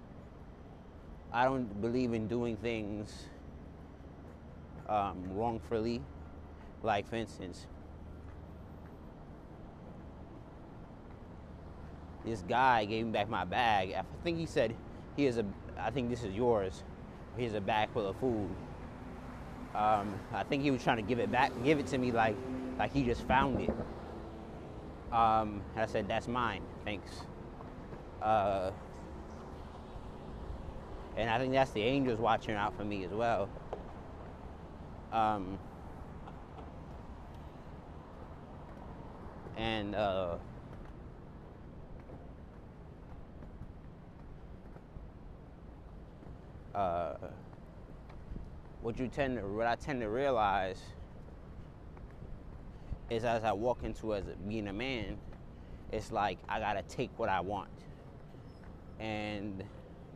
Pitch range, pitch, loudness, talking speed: 80-115 Hz, 100 Hz, -35 LUFS, 105 wpm